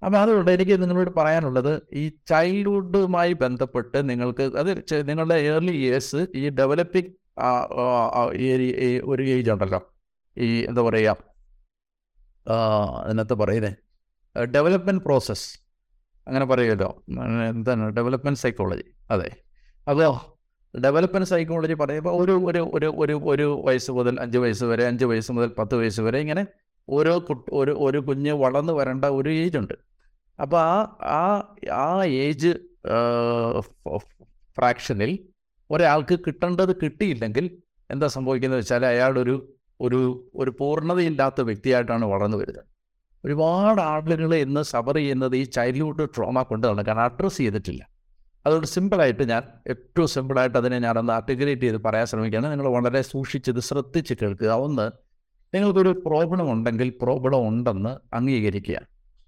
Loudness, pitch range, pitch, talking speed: -23 LUFS, 120-160 Hz, 130 Hz, 120 wpm